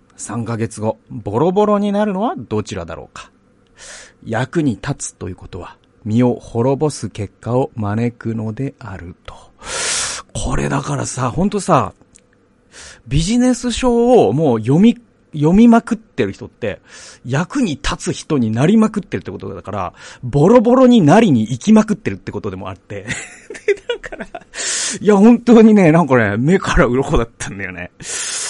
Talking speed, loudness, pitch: 300 characters per minute, -15 LUFS, 130 Hz